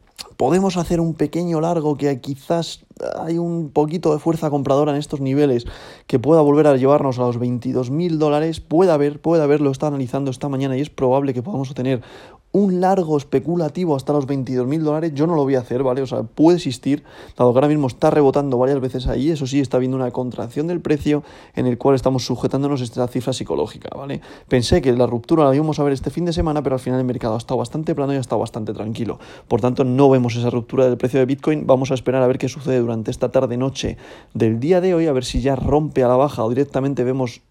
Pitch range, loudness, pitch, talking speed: 125-150 Hz, -19 LUFS, 135 Hz, 235 wpm